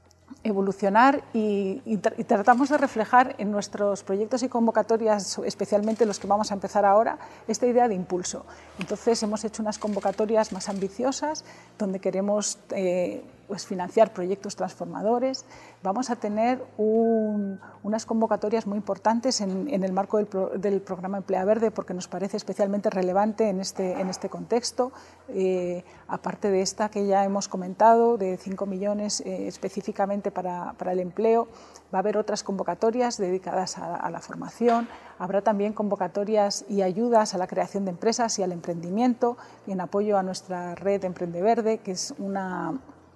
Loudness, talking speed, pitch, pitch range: -26 LUFS, 165 wpm, 205 Hz, 190-225 Hz